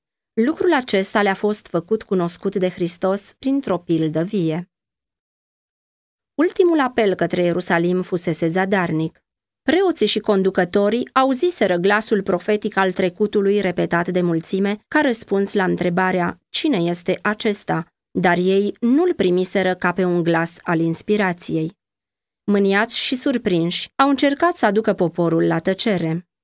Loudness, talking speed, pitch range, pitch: -19 LUFS, 125 wpm, 175-215 Hz, 190 Hz